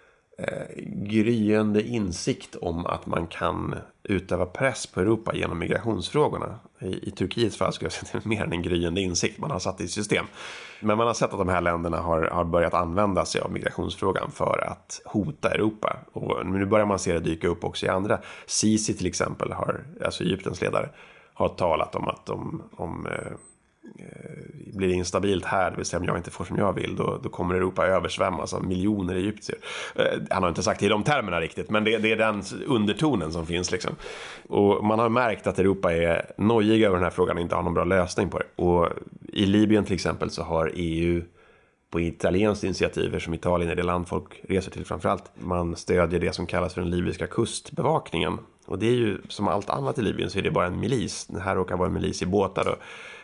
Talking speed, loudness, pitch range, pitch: 220 wpm, -26 LUFS, 85-105 Hz, 95 Hz